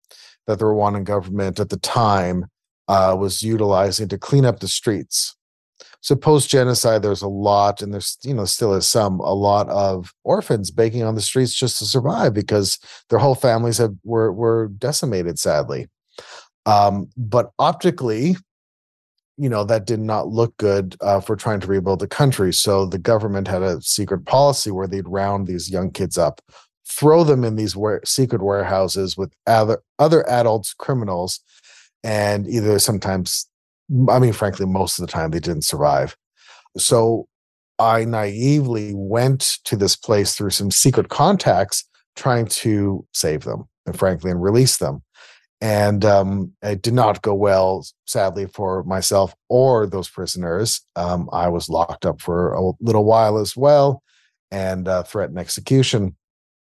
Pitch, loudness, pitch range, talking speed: 105 Hz, -19 LUFS, 95-115 Hz, 160 wpm